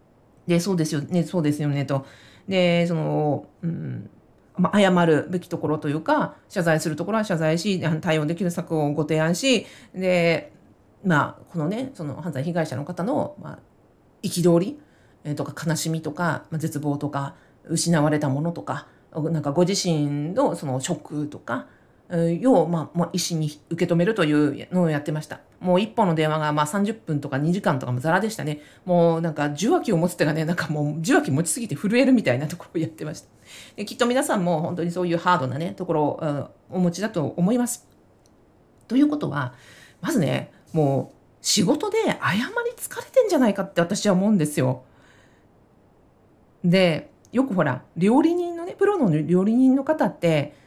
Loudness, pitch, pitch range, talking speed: -23 LUFS, 165 Hz, 150-185 Hz, 300 characters per minute